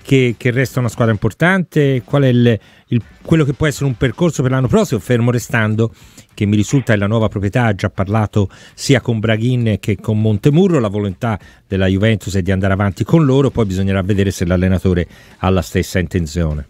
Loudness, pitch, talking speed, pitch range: -16 LUFS, 110 Hz, 200 wpm, 100-130 Hz